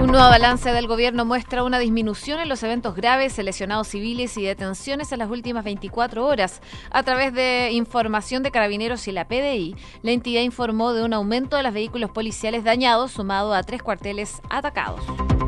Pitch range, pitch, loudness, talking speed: 215-250 Hz, 235 Hz, -22 LUFS, 180 wpm